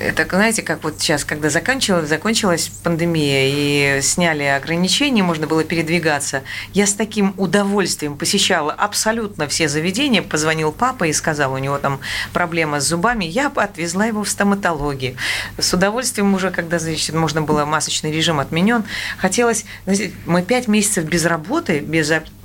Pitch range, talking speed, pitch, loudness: 155-200 Hz, 145 wpm, 170 Hz, -18 LUFS